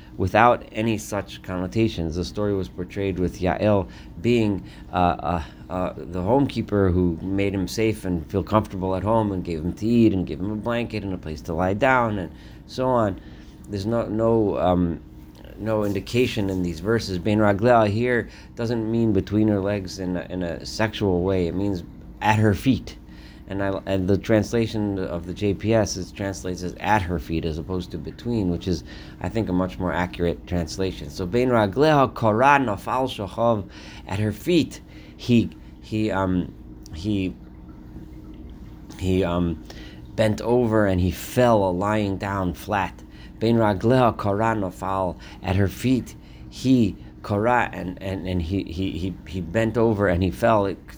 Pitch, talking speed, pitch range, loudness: 95 Hz, 155 wpm, 85-110 Hz, -23 LUFS